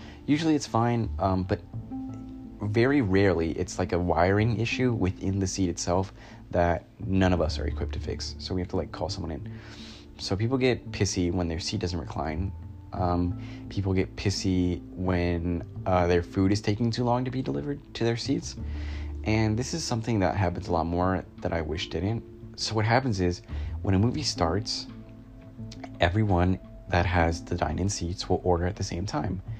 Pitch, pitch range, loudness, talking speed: 95 Hz, 90-115 Hz, -28 LUFS, 185 wpm